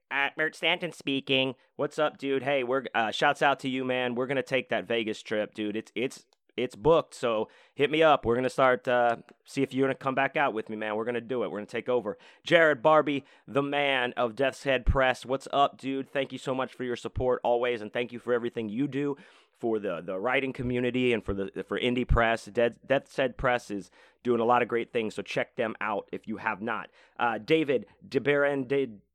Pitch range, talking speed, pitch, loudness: 120-140 Hz, 235 wpm, 130 Hz, -28 LUFS